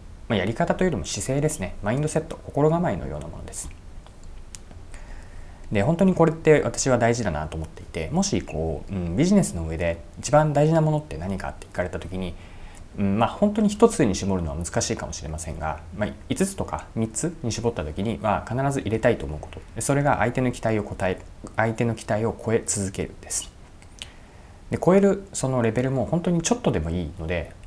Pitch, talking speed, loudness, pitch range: 100 Hz, 395 characters per minute, -24 LUFS, 85-130 Hz